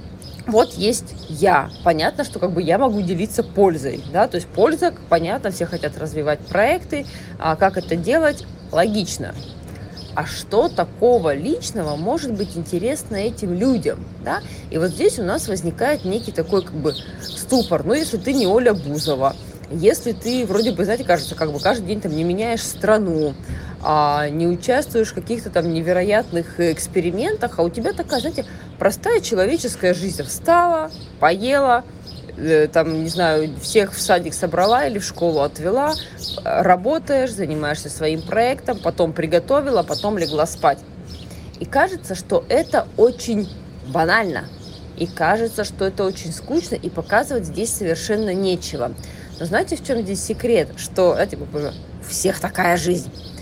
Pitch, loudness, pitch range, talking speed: 190 Hz, -20 LUFS, 165-235 Hz, 150 wpm